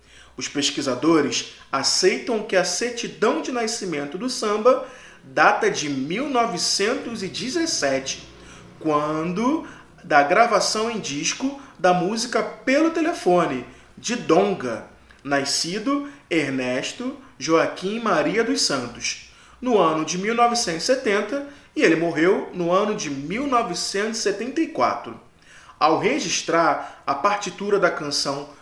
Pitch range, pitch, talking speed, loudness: 160-245 Hz, 205 Hz, 100 wpm, -22 LUFS